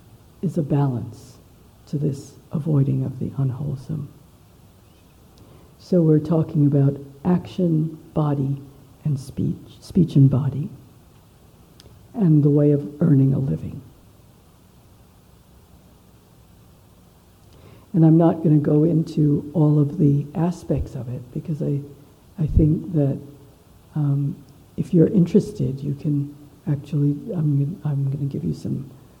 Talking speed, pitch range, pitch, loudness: 120 wpm, 140-160 Hz, 145 Hz, -21 LUFS